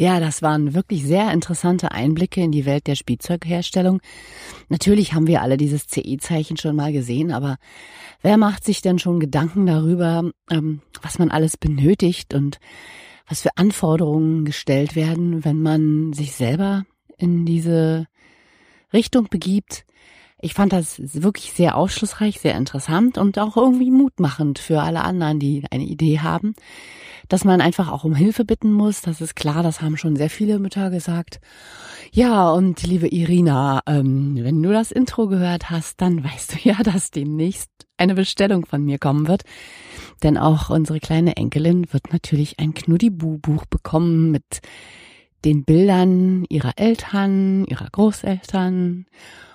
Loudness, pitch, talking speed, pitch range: -19 LUFS, 170 Hz, 150 wpm, 155-190 Hz